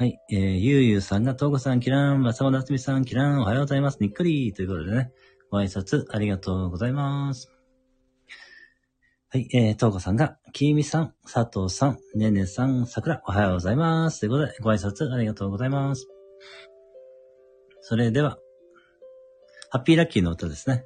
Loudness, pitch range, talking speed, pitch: -24 LUFS, 110-140 Hz, 375 characters per minute, 130 Hz